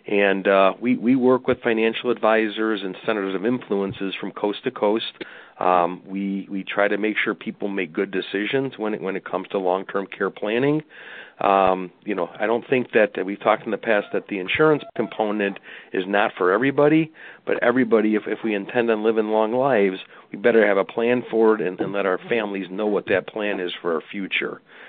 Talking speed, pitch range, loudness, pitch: 210 wpm, 100-120 Hz, -22 LUFS, 110 Hz